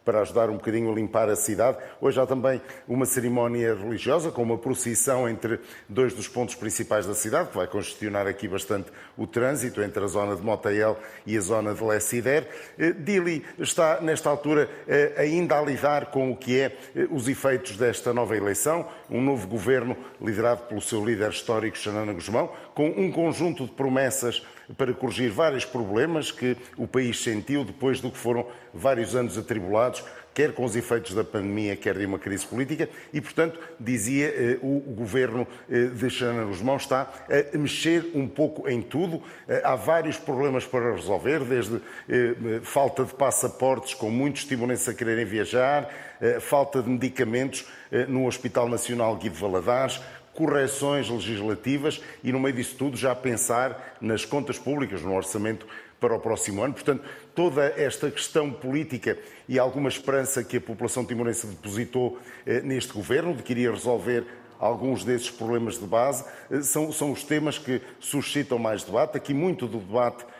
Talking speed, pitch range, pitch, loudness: 170 wpm, 115-135 Hz, 125 Hz, -26 LUFS